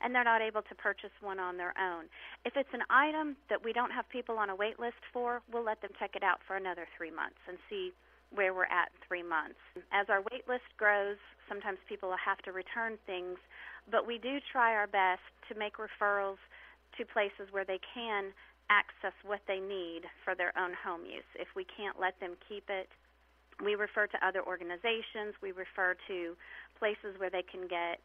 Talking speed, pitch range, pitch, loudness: 205 wpm, 185-225 Hz, 200 Hz, -35 LUFS